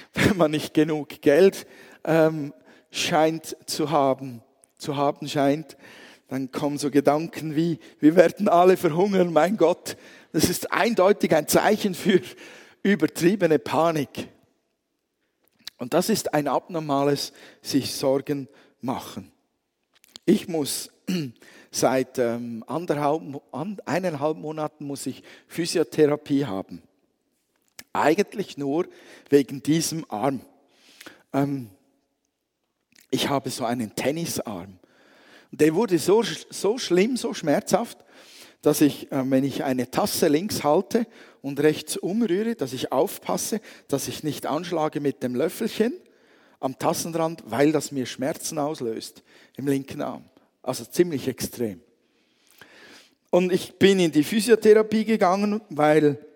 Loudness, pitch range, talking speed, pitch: -24 LUFS, 140-180 Hz, 115 wpm, 155 Hz